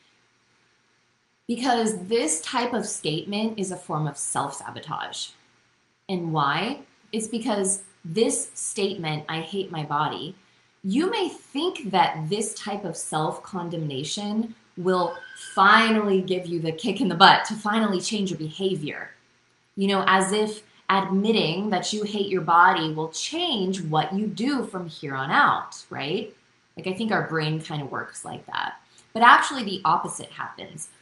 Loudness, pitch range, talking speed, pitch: -24 LUFS, 160-215 Hz, 155 wpm, 190 Hz